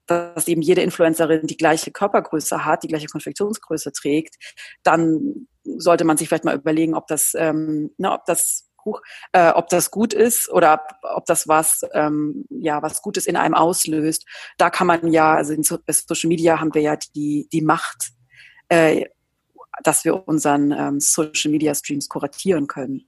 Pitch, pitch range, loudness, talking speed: 160 Hz, 155-170 Hz, -19 LUFS, 170 wpm